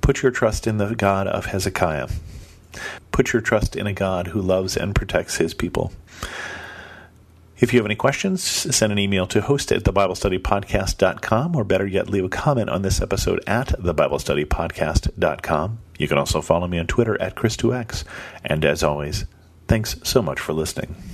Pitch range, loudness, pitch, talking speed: 90-110 Hz, -21 LUFS, 100 Hz, 170 wpm